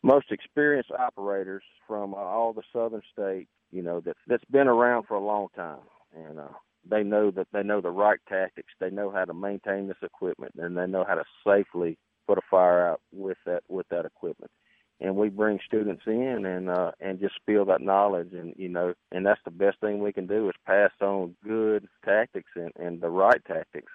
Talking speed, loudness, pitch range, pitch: 205 wpm, -27 LUFS, 90-105 Hz, 100 Hz